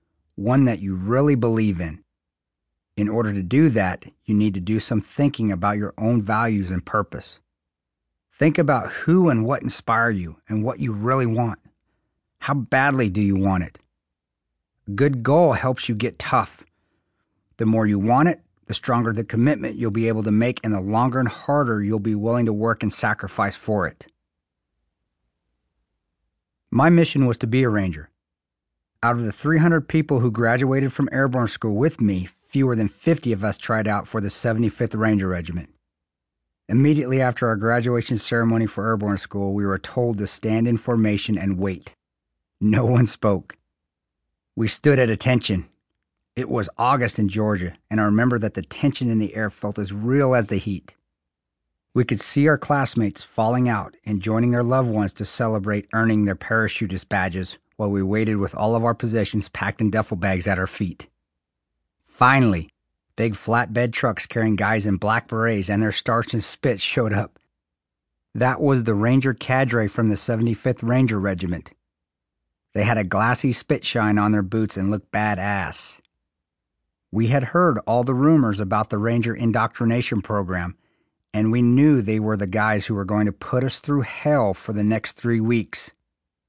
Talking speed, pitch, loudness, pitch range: 175 wpm, 110 Hz, -21 LUFS, 95-120 Hz